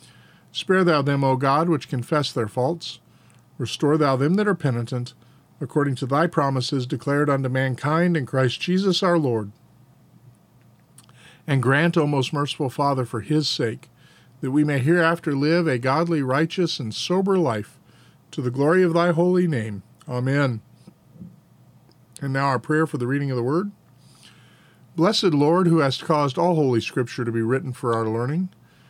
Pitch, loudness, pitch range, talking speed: 140 Hz, -22 LUFS, 125-165 Hz, 165 wpm